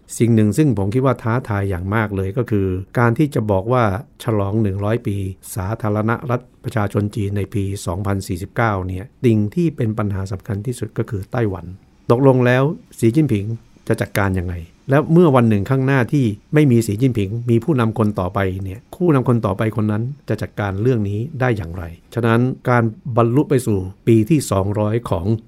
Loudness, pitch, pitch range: -19 LUFS, 110 Hz, 100-125 Hz